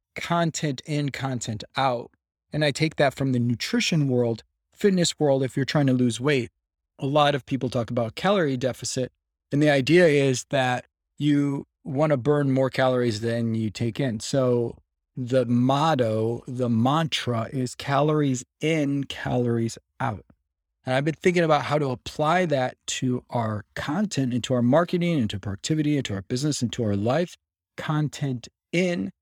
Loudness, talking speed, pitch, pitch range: -24 LUFS, 160 wpm, 130 Hz, 120-150 Hz